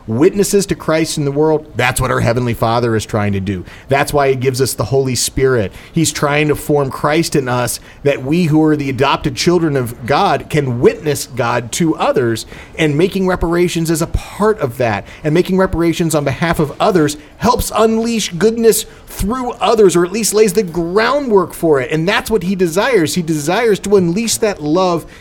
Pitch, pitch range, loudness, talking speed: 155 Hz, 130-185 Hz, -14 LUFS, 200 wpm